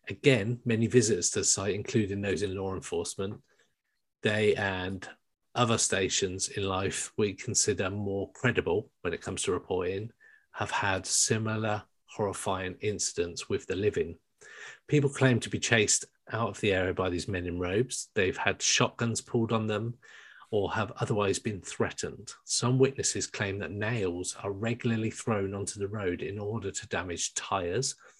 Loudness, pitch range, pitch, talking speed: -30 LUFS, 95-115 Hz, 105 Hz, 160 wpm